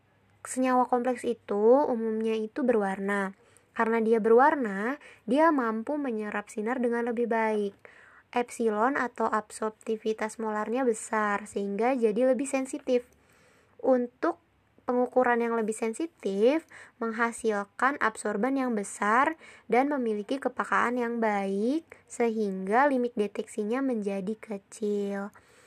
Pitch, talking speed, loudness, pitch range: 230 Hz, 105 wpm, -28 LUFS, 215-250 Hz